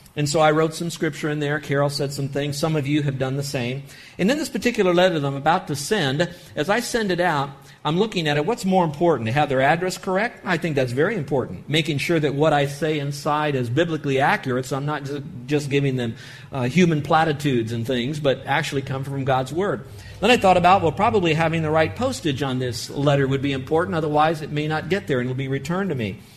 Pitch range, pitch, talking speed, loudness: 135-170 Hz, 150 Hz, 245 wpm, -22 LUFS